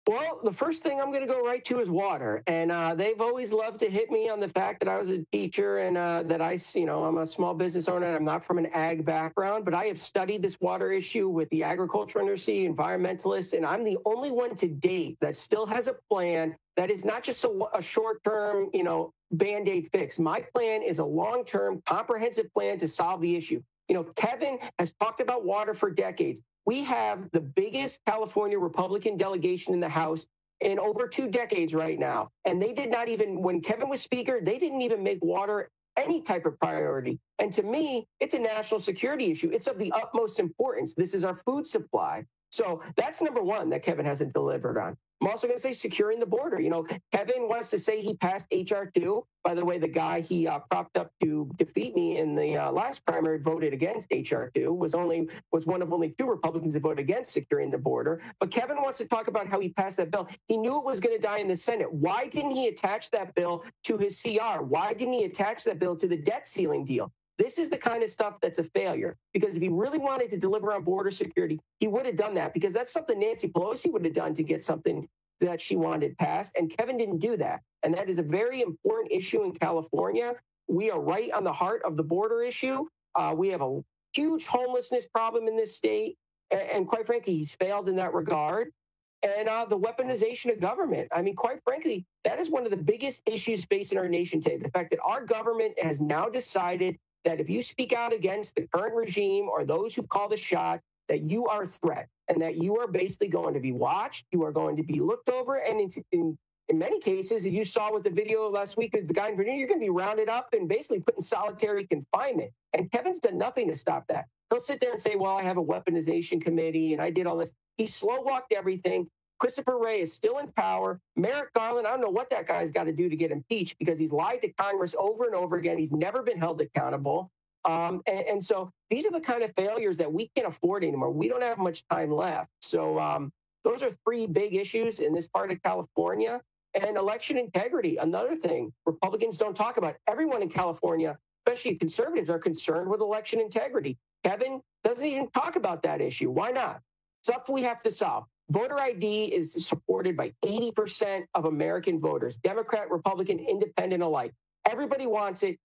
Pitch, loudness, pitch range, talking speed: 215 Hz, -29 LUFS, 180-275 Hz, 220 wpm